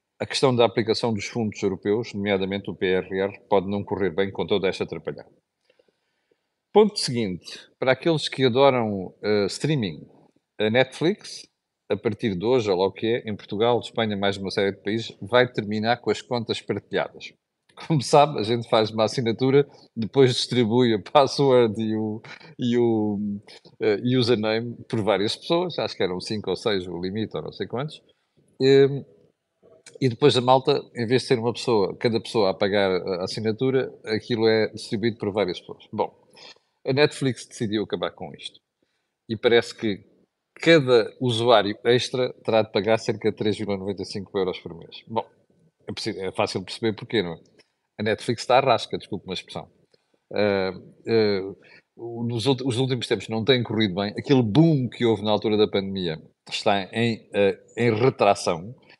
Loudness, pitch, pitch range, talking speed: -23 LUFS, 115 Hz, 105-130 Hz, 170 wpm